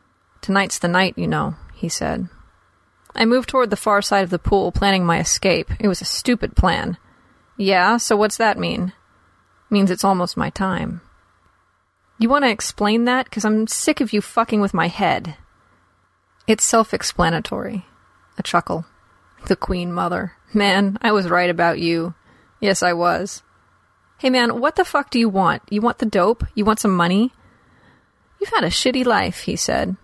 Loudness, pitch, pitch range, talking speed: -19 LUFS, 200 Hz, 175-230 Hz, 170 wpm